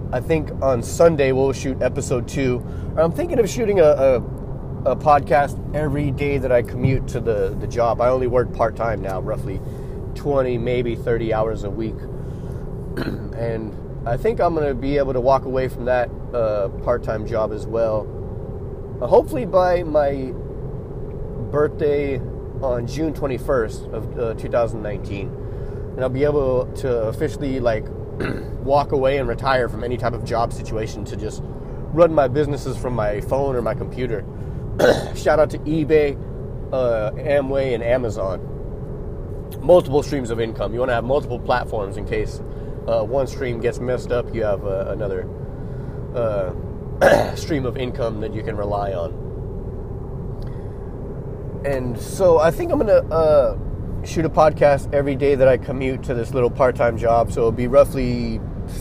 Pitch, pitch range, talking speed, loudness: 130 Hz, 115-140 Hz, 165 wpm, -21 LUFS